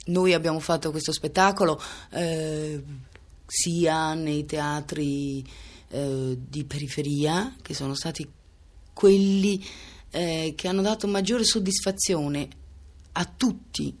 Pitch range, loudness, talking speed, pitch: 140-185 Hz, -26 LUFS, 105 wpm, 155 Hz